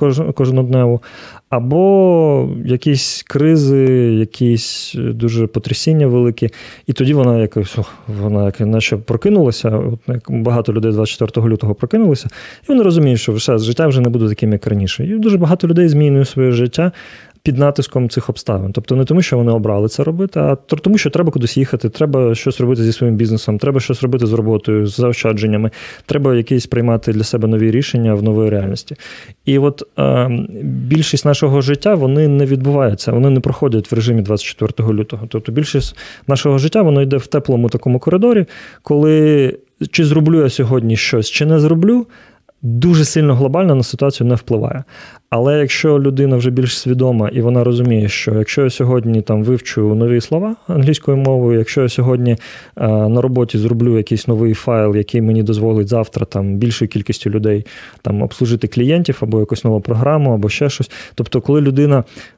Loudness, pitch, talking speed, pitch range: -14 LUFS, 125 Hz, 170 wpm, 115-145 Hz